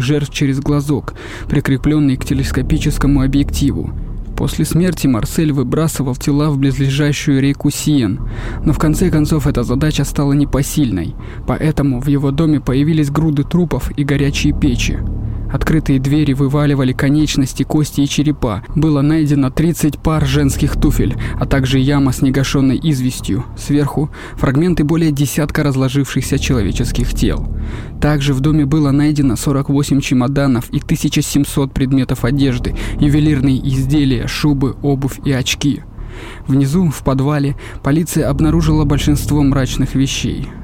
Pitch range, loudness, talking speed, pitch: 135-150 Hz, -15 LUFS, 125 wpm, 140 Hz